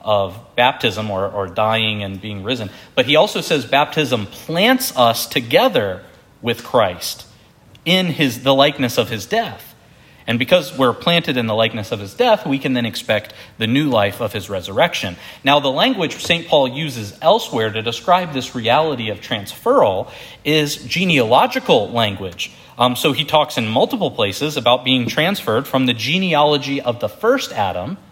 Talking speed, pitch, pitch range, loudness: 165 wpm, 130 Hz, 110-150 Hz, -17 LUFS